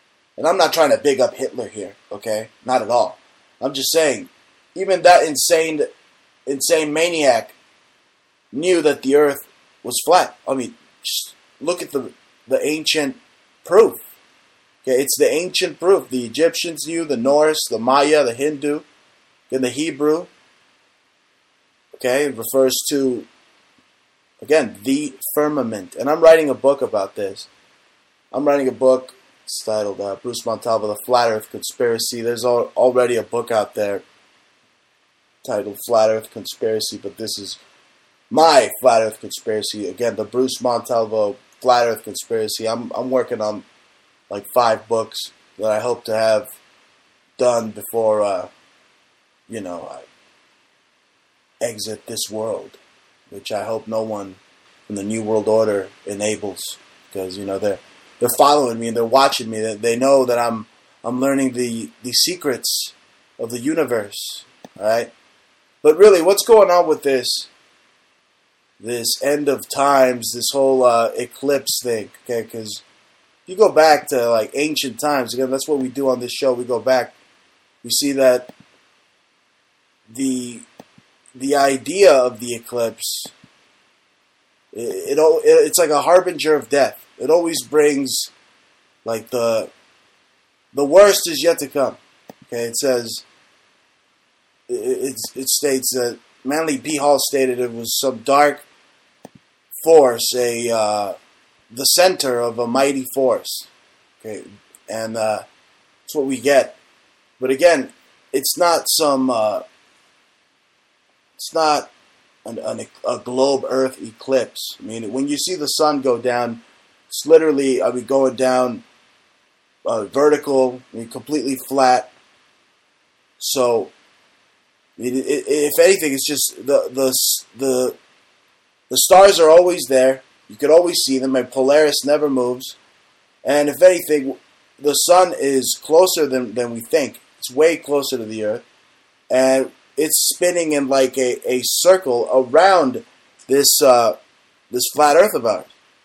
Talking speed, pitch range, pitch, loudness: 145 wpm, 115-150 Hz, 130 Hz, -17 LUFS